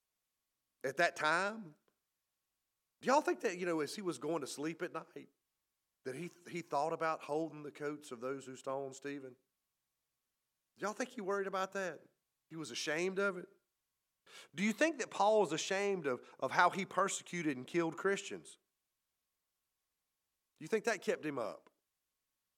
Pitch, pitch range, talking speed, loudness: 175 Hz, 150-195 Hz, 170 wpm, -37 LUFS